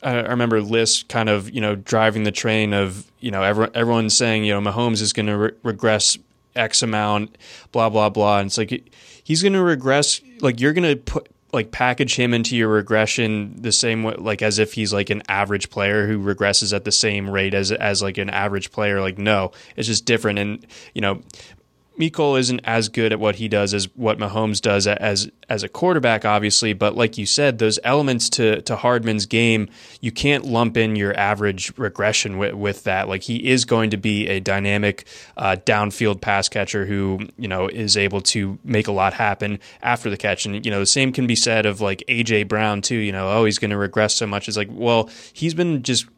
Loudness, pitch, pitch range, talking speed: -19 LUFS, 110 Hz, 100-115 Hz, 215 wpm